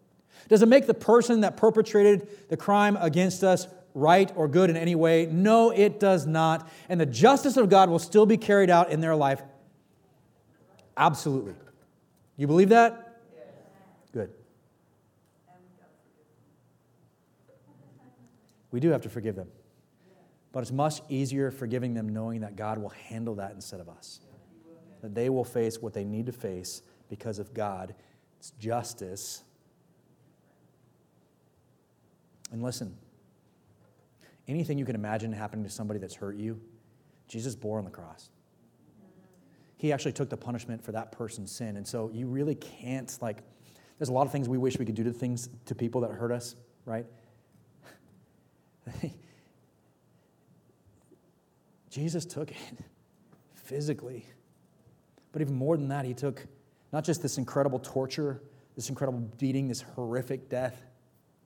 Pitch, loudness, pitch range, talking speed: 130 Hz, -27 LUFS, 115-165 Hz, 145 wpm